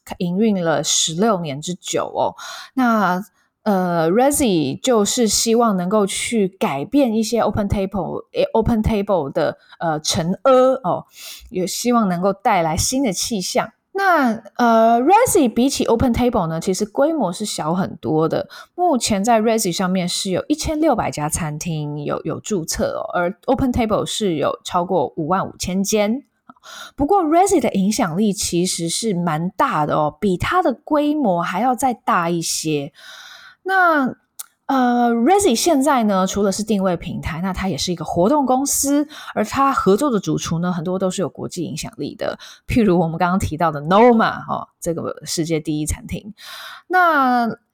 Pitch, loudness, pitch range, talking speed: 215 Hz, -18 LUFS, 180-265 Hz, 295 characters per minute